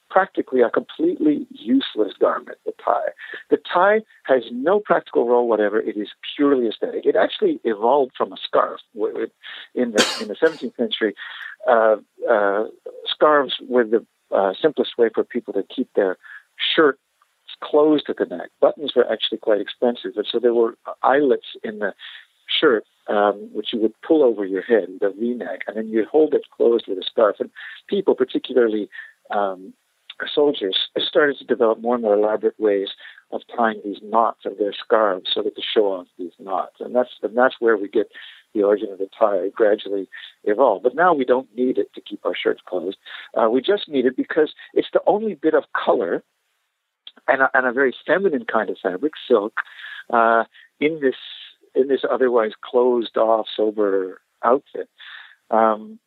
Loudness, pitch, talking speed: -20 LUFS, 130 Hz, 180 wpm